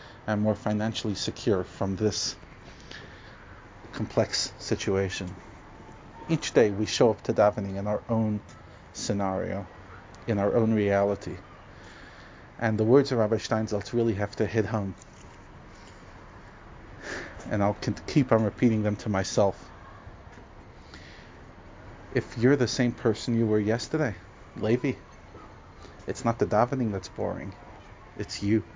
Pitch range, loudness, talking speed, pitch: 95-115 Hz, -27 LUFS, 125 wpm, 105 Hz